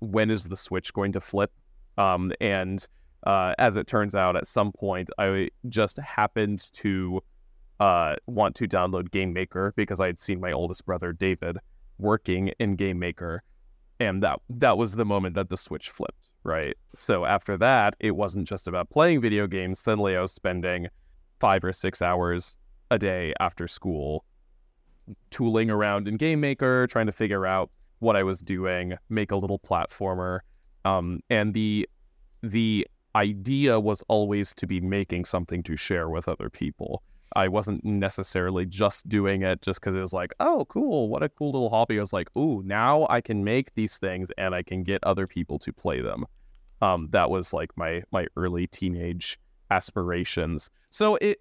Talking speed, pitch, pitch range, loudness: 180 wpm, 95 Hz, 90-105 Hz, -26 LUFS